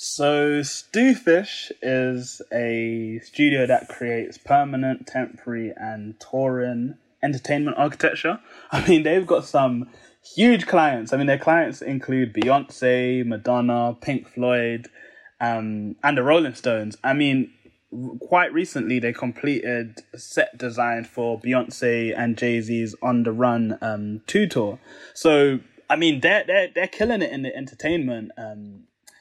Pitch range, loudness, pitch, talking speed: 115-145 Hz, -22 LUFS, 125 Hz, 140 wpm